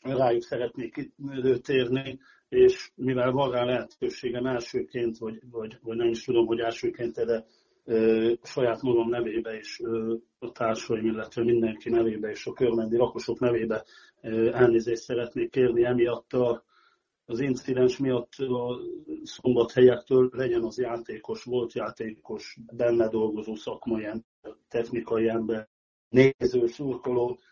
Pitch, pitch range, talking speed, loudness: 120 Hz, 115-125 Hz, 125 wpm, -27 LUFS